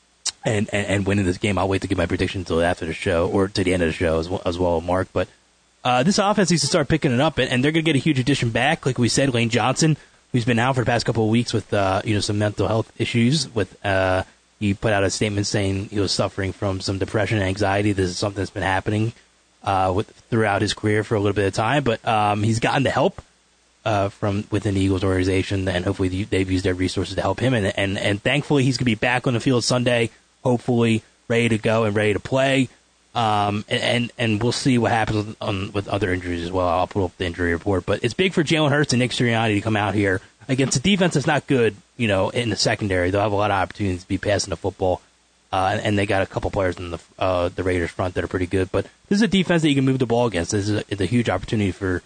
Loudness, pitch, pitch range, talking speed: -21 LUFS, 105 Hz, 95-120 Hz, 275 wpm